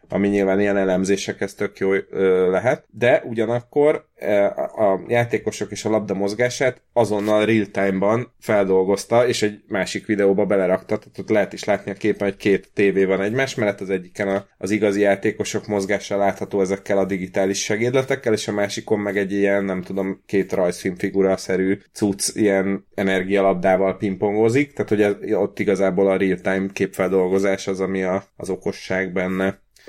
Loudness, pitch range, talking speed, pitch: -21 LUFS, 95-105 Hz, 145 wpm, 100 Hz